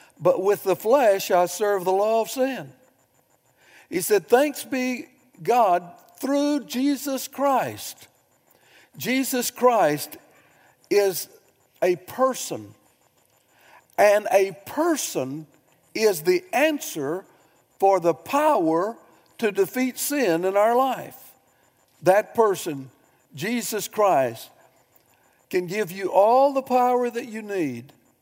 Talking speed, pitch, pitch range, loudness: 110 wpm, 220 Hz, 185-265 Hz, -23 LUFS